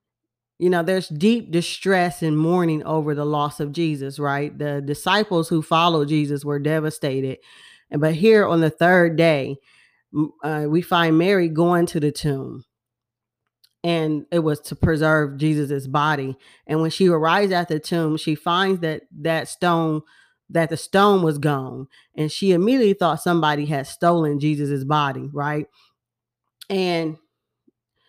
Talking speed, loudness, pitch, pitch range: 150 wpm, -20 LUFS, 155 Hz, 145-170 Hz